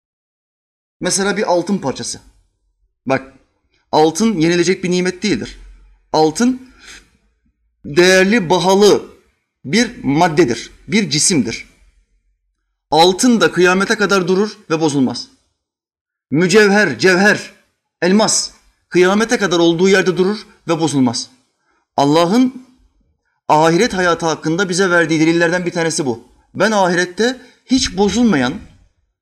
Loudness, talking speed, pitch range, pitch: -14 LUFS, 100 wpm, 150-205 Hz, 180 Hz